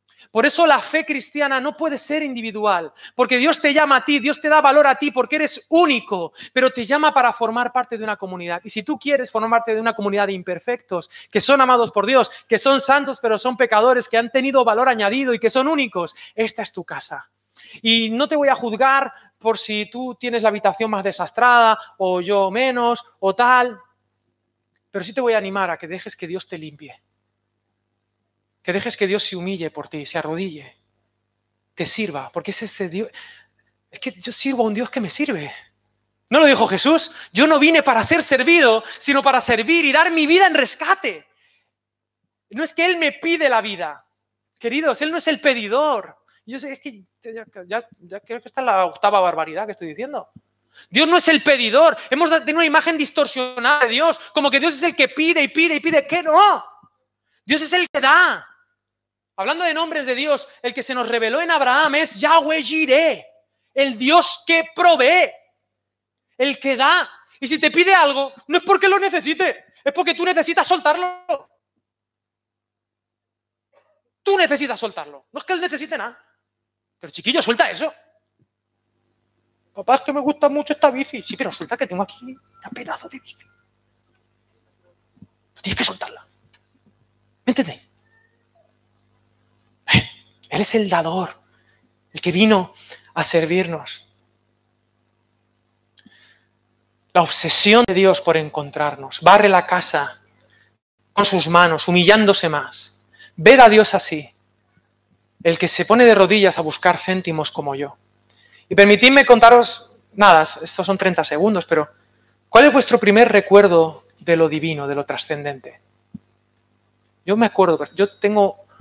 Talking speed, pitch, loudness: 175 wpm, 220 Hz, -16 LUFS